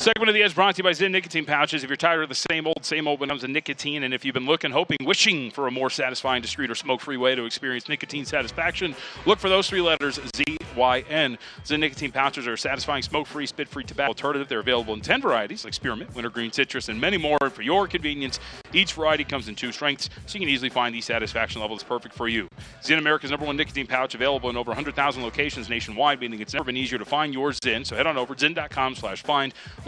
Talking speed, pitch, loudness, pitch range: 250 wpm, 140 Hz, -24 LUFS, 125-150 Hz